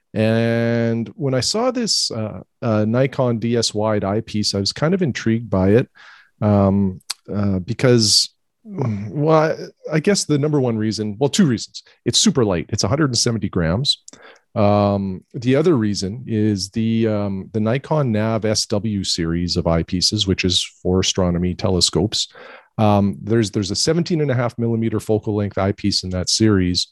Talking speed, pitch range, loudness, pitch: 160 wpm, 100-120 Hz, -19 LUFS, 110 Hz